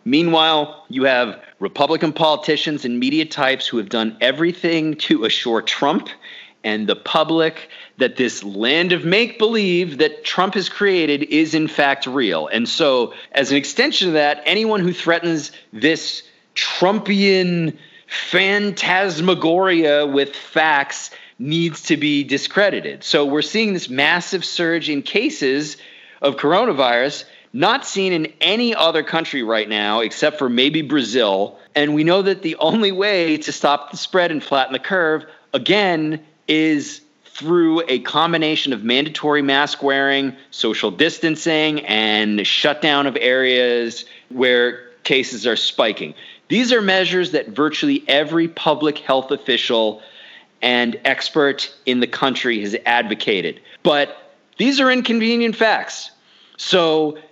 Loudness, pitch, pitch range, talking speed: -17 LUFS, 155 Hz, 140-180 Hz, 135 wpm